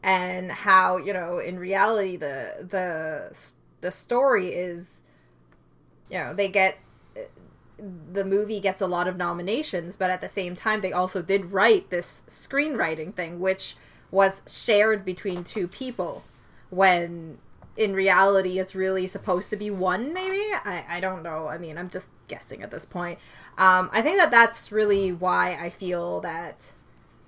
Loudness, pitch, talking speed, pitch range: -24 LUFS, 185 Hz, 160 wpm, 175-200 Hz